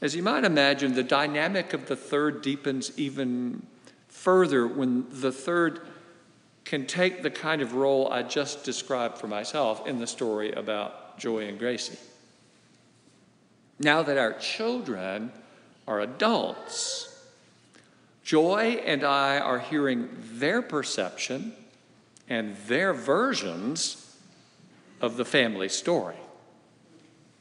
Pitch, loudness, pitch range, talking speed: 140 Hz, -27 LUFS, 125-165 Hz, 115 wpm